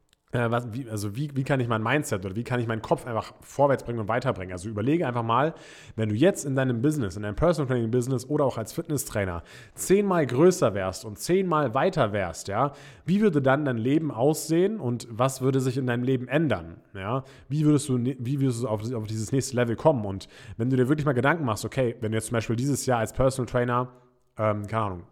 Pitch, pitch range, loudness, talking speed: 125 Hz, 110-145 Hz, -26 LUFS, 230 wpm